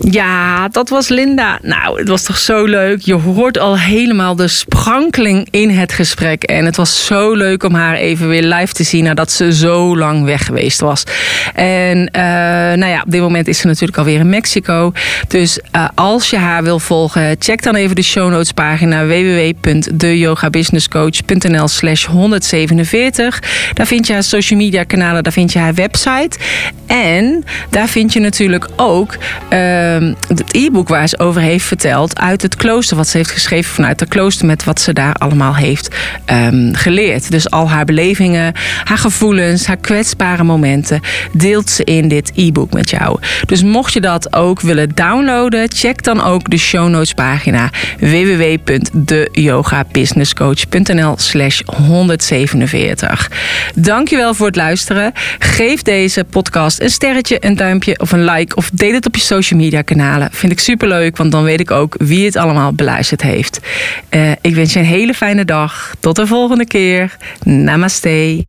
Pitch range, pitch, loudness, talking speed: 160-205 Hz, 175 Hz, -11 LUFS, 170 wpm